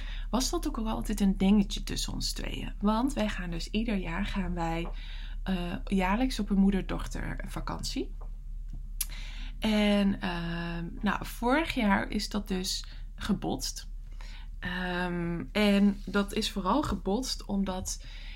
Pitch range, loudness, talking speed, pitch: 170-210 Hz, -31 LUFS, 130 wpm, 195 Hz